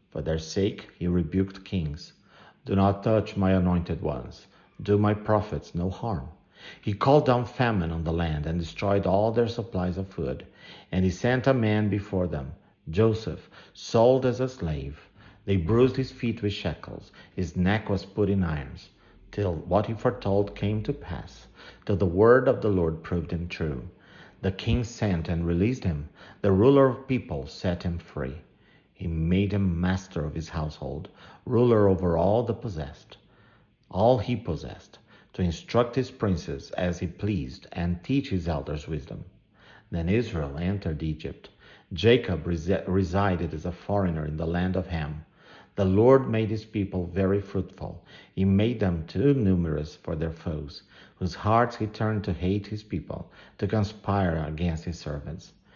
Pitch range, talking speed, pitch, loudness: 85-105 Hz, 165 wpm, 95 Hz, -27 LUFS